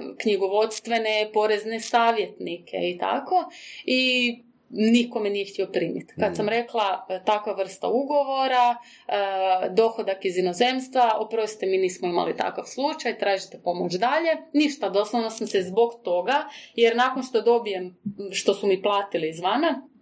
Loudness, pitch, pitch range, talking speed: -24 LUFS, 220 Hz, 195-245 Hz, 135 wpm